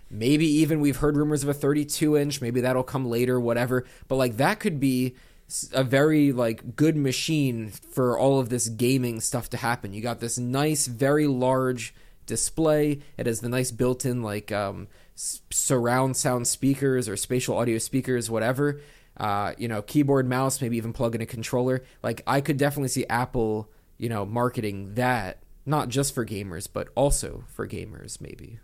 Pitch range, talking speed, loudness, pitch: 115-140 Hz, 175 wpm, -25 LUFS, 125 Hz